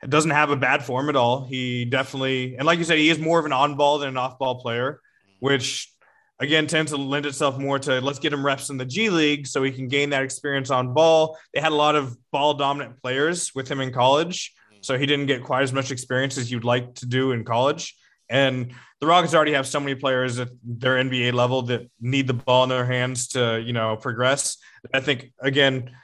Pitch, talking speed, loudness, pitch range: 135 Hz, 230 wpm, -22 LUFS, 125-145 Hz